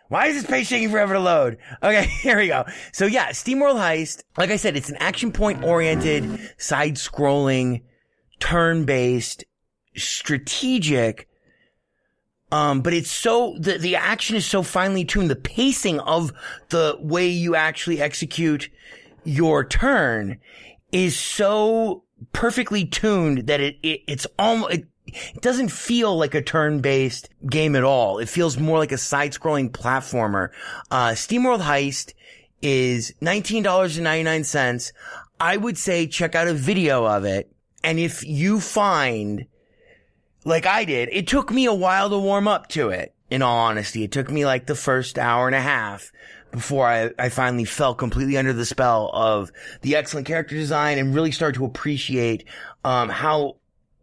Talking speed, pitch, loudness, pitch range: 155 wpm, 155 Hz, -21 LUFS, 135-190 Hz